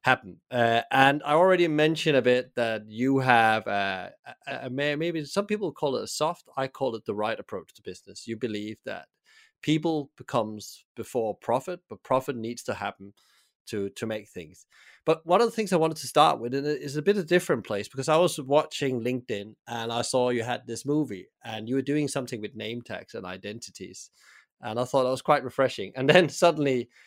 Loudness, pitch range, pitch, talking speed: -26 LUFS, 115-150 Hz, 130 Hz, 210 wpm